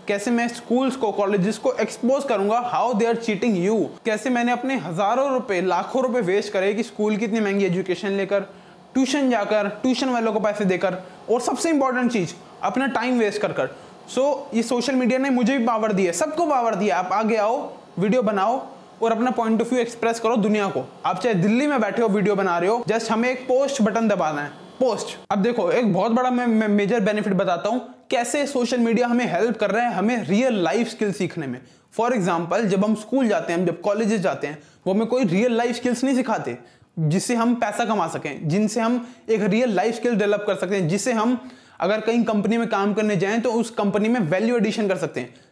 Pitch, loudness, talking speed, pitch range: 220 Hz, -22 LUFS, 170 wpm, 195-245 Hz